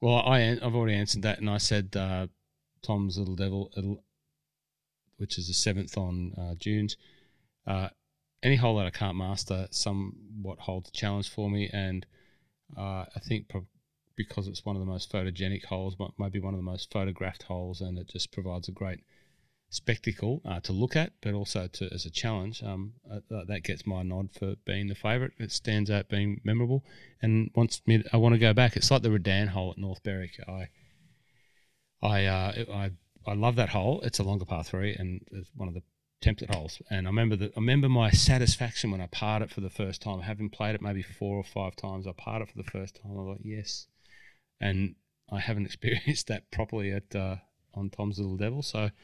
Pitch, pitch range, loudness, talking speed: 100 Hz, 95-110 Hz, -31 LUFS, 205 wpm